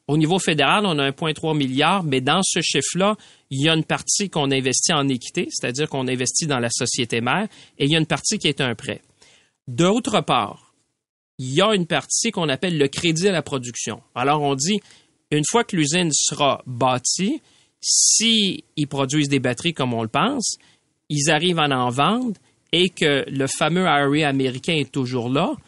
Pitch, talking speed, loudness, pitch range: 150 Hz, 195 wpm, -20 LUFS, 135-180 Hz